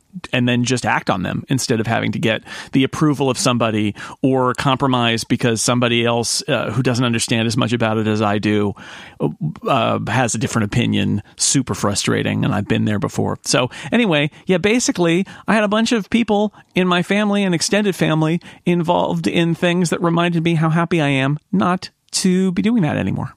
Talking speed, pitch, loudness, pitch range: 195 wpm, 140 Hz, -18 LUFS, 120-180 Hz